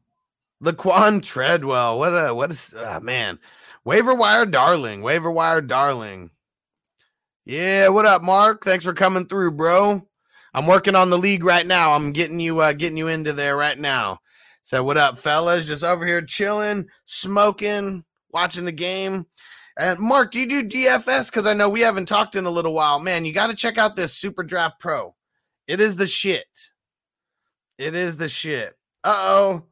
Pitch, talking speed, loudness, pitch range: 185 Hz, 180 wpm, -19 LUFS, 165-205 Hz